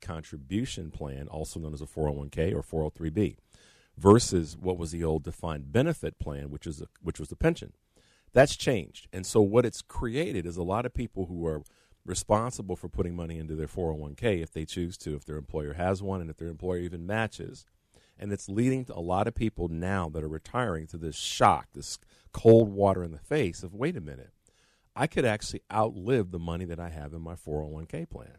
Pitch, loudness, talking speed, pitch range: 85 Hz, -30 LUFS, 205 wpm, 80-100 Hz